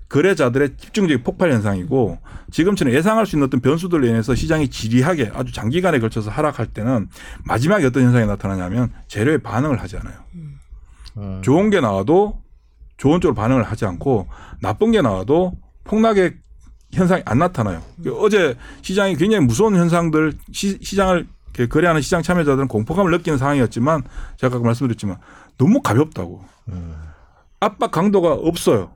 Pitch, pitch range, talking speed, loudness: 130 Hz, 110-175 Hz, 380 characters per minute, -18 LUFS